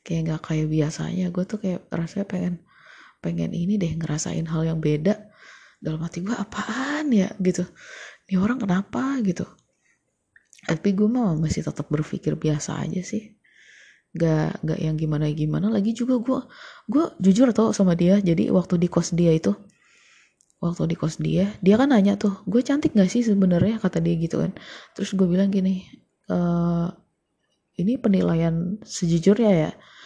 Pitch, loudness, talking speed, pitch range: 185 Hz, -23 LUFS, 160 wpm, 165-210 Hz